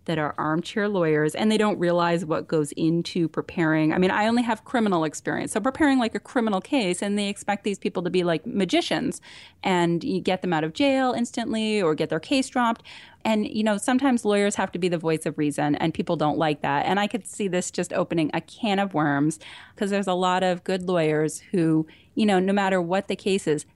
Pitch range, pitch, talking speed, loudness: 165-215 Hz, 185 Hz, 230 wpm, -24 LUFS